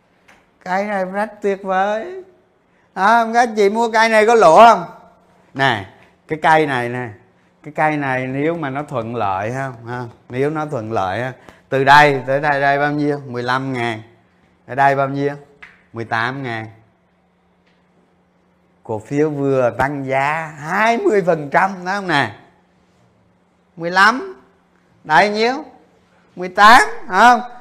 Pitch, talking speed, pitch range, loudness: 145 Hz, 140 wpm, 125-195 Hz, -16 LUFS